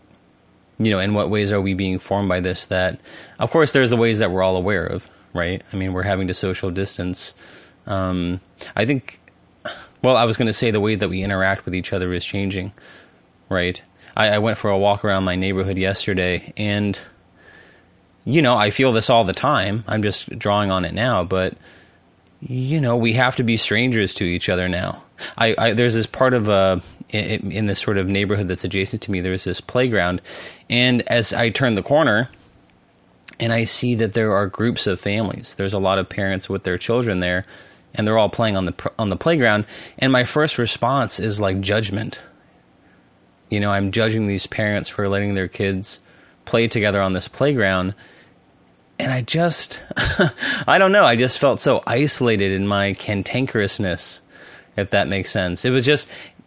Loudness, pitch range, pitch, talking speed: -19 LUFS, 95-115 Hz, 100 Hz, 195 wpm